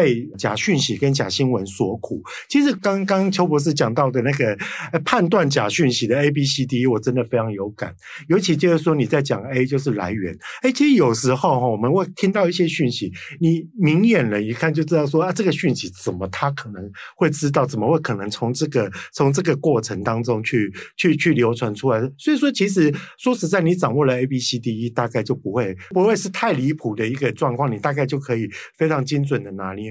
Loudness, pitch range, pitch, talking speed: -20 LUFS, 120-170 Hz, 140 Hz, 325 characters per minute